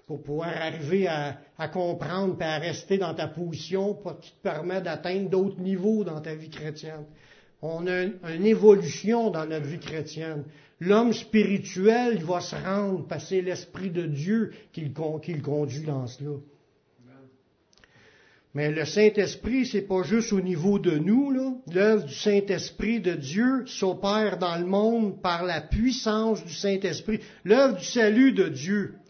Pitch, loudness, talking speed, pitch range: 185 Hz, -26 LUFS, 165 wpm, 155-205 Hz